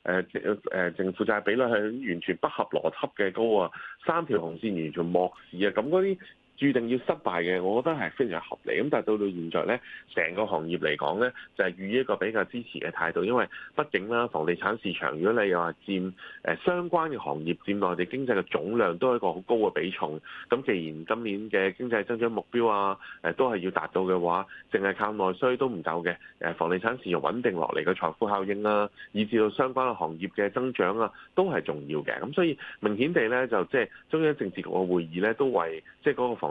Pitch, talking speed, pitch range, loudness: 100 Hz, 330 characters per minute, 90-120 Hz, -28 LUFS